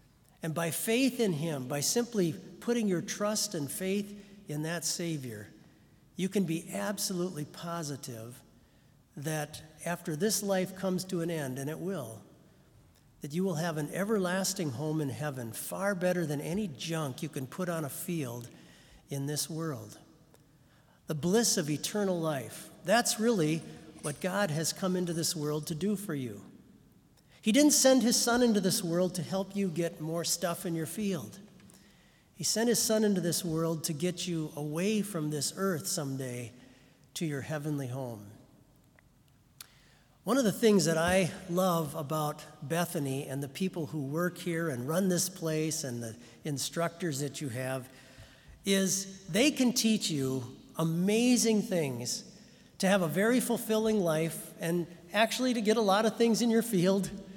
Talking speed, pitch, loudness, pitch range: 165 wpm, 170 Hz, -31 LUFS, 150-195 Hz